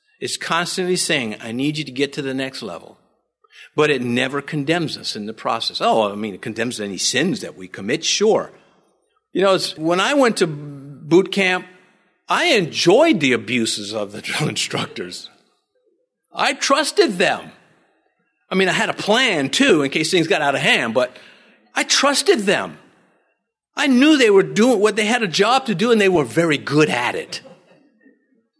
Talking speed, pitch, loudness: 185 wpm, 180 Hz, -18 LUFS